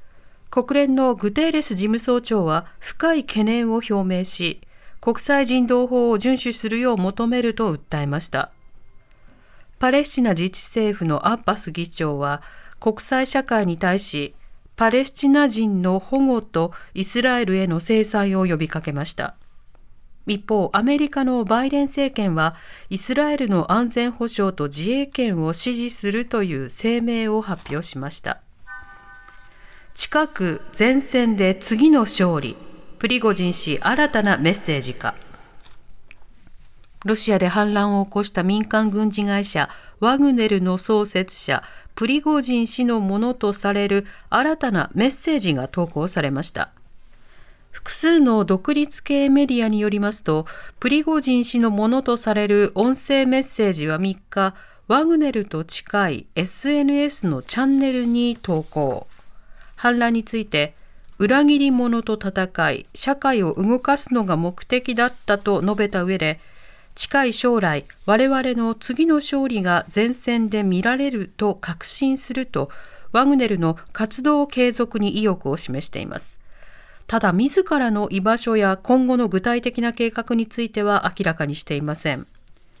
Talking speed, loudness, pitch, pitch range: 275 characters per minute, -20 LUFS, 220 Hz, 185-250 Hz